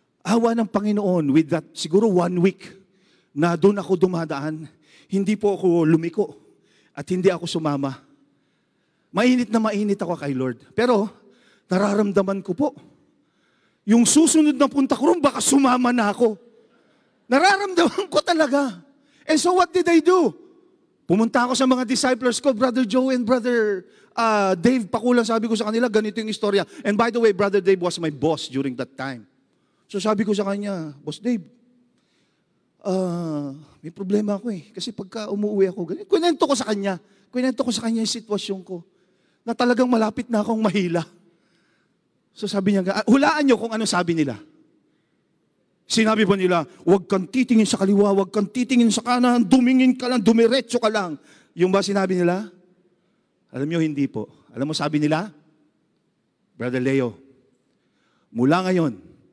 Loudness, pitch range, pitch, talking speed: -21 LUFS, 180-245 Hz, 210 Hz, 160 wpm